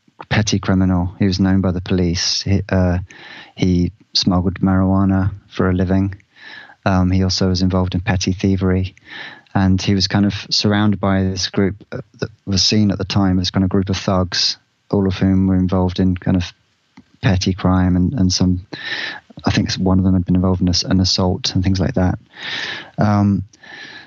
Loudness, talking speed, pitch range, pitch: -17 LUFS, 185 wpm, 95-100 Hz, 95 Hz